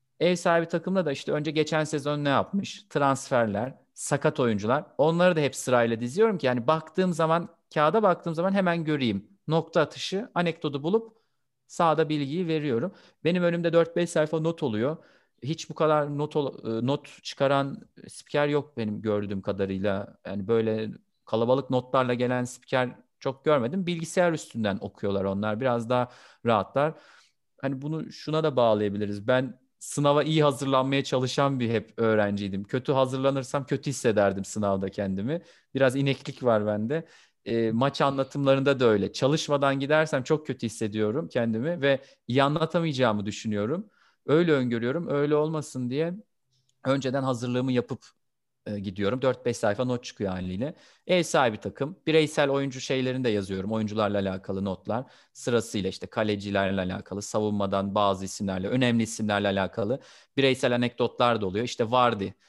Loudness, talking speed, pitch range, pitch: -27 LUFS, 140 wpm, 110-155 Hz, 130 Hz